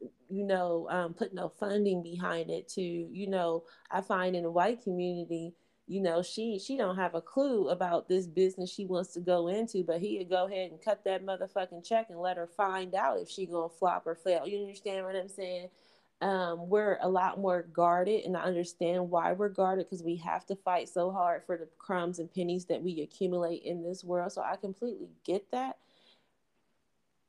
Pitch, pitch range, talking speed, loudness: 180 Hz, 175-195 Hz, 205 wpm, -33 LUFS